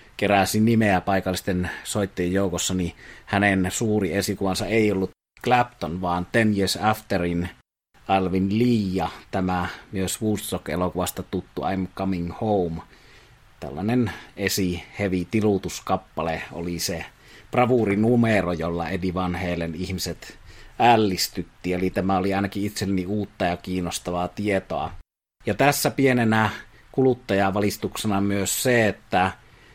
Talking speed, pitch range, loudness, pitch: 110 wpm, 90-105 Hz, -24 LUFS, 95 Hz